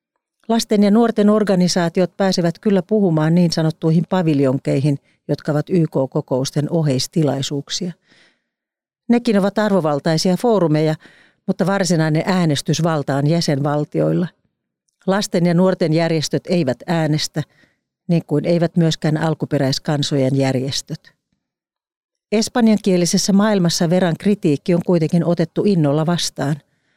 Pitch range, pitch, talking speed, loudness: 150-190 Hz, 170 Hz, 95 wpm, -18 LUFS